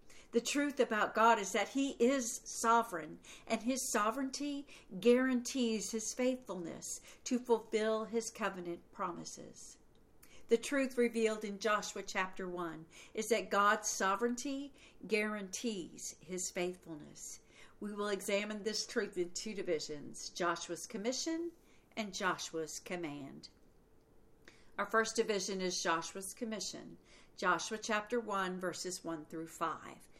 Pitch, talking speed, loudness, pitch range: 215 Hz, 120 wpm, -36 LUFS, 185-235 Hz